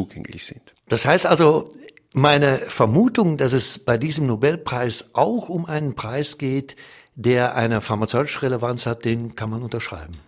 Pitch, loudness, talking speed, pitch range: 130 Hz, -20 LUFS, 140 wpm, 115-150 Hz